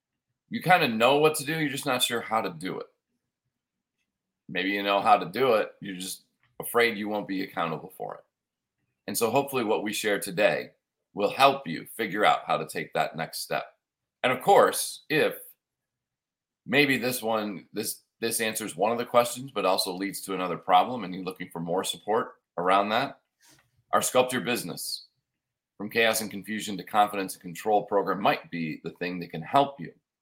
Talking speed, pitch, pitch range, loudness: 195 wpm, 110 Hz, 95-125 Hz, -27 LUFS